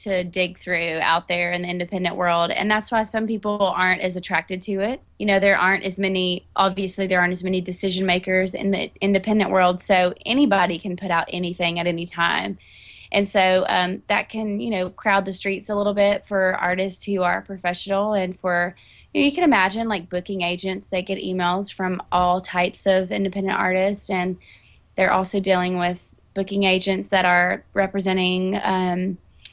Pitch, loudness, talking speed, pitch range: 185 Hz, -21 LUFS, 190 wpm, 180-195 Hz